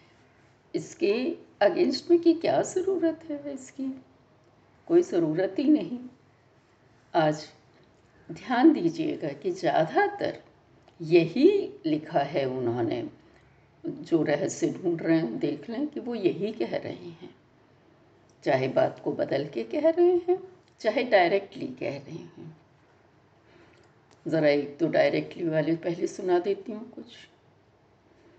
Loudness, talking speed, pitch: -27 LUFS, 120 wpm, 250 Hz